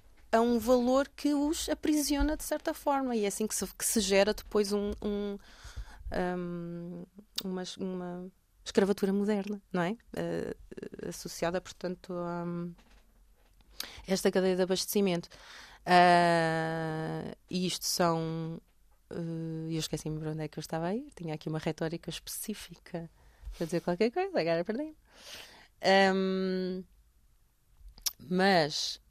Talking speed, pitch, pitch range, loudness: 130 wpm, 185 Hz, 170-210 Hz, -31 LUFS